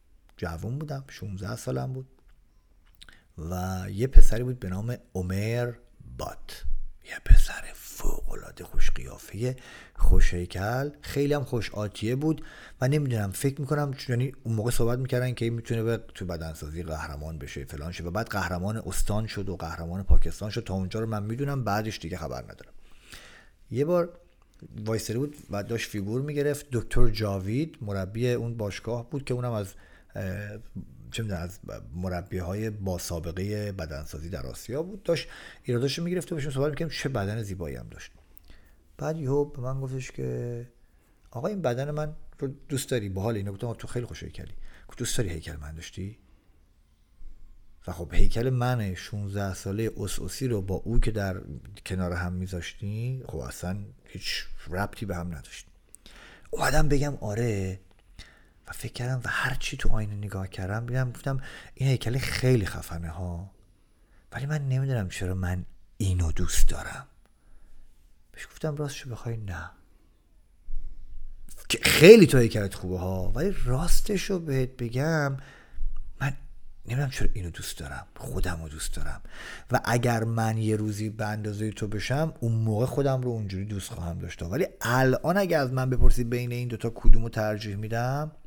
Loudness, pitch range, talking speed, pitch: -29 LUFS, 90-125 Hz, 155 wpm, 105 Hz